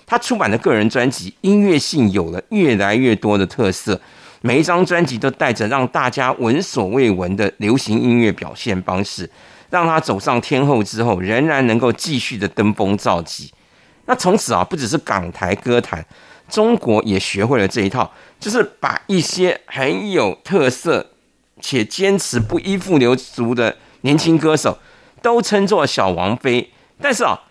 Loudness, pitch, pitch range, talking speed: -17 LUFS, 125 Hz, 110-165 Hz, 250 characters per minute